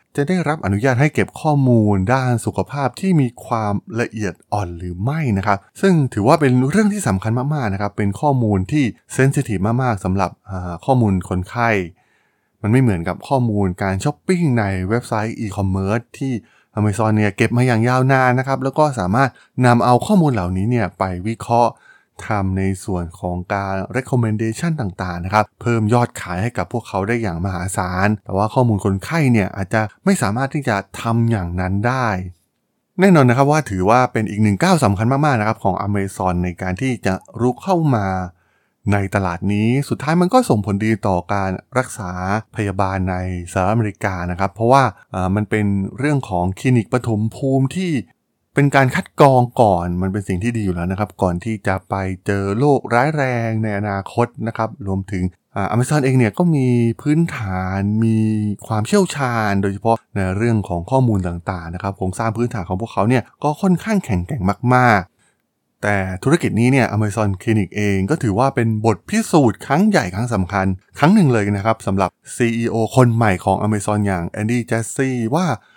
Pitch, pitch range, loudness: 110 Hz, 95-125 Hz, -18 LUFS